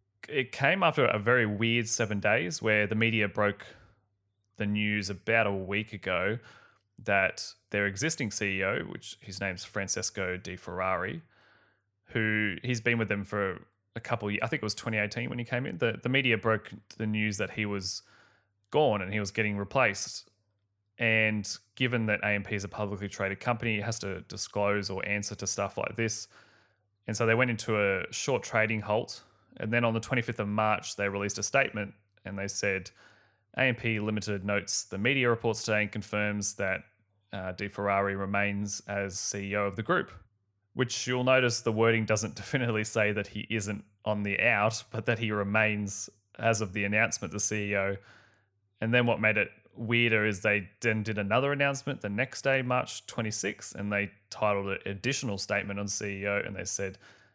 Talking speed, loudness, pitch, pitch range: 185 wpm, -29 LUFS, 105 Hz, 100-115 Hz